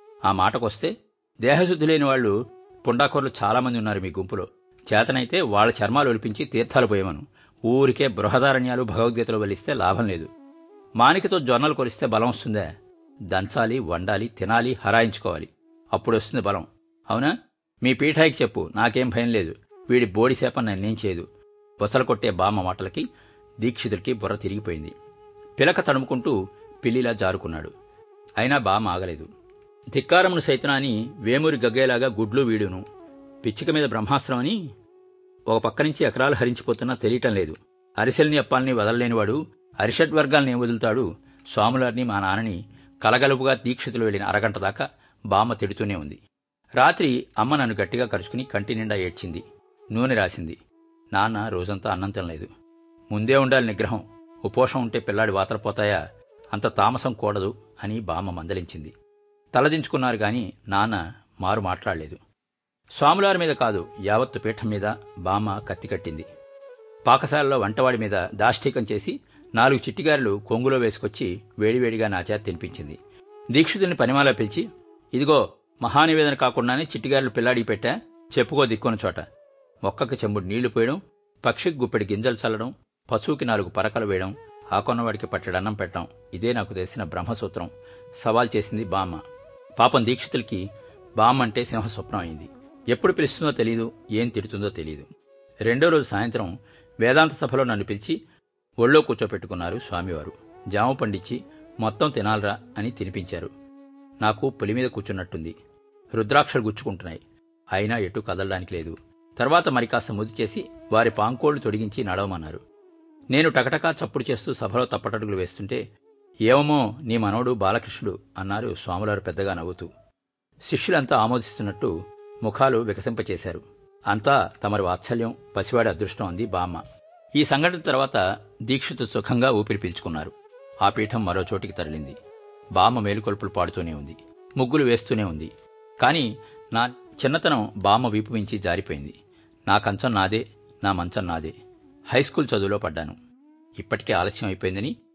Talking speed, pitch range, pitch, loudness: 115 wpm, 105-150 Hz, 120 Hz, -23 LUFS